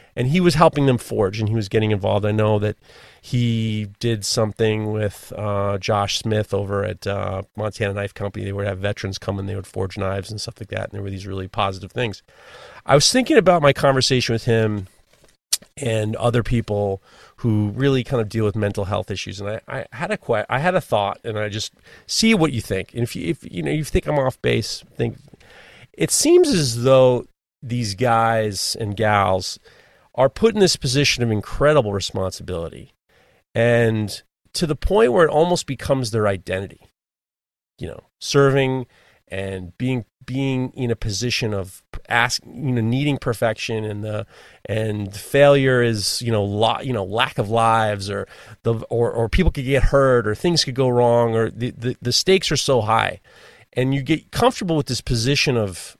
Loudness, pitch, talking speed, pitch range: -20 LUFS, 115 Hz, 195 wpm, 100-130 Hz